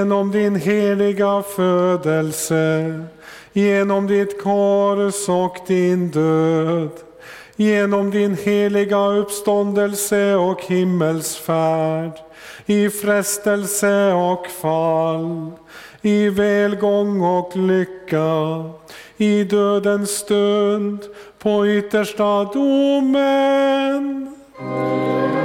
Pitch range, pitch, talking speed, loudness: 170-205 Hz, 200 Hz, 70 wpm, -18 LUFS